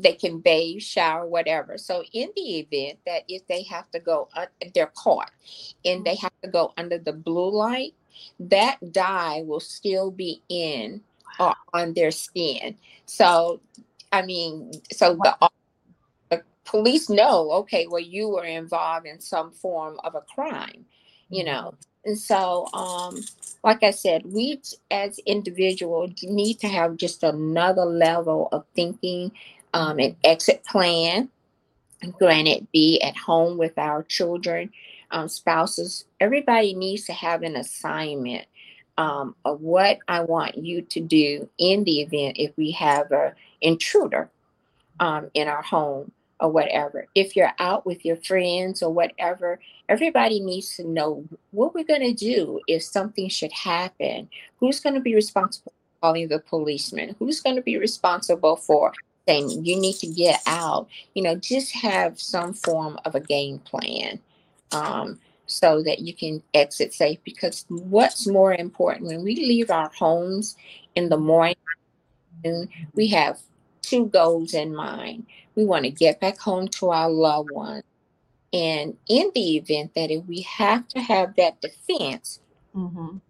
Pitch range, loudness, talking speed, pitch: 160-195 Hz, -23 LUFS, 155 wpm, 175 Hz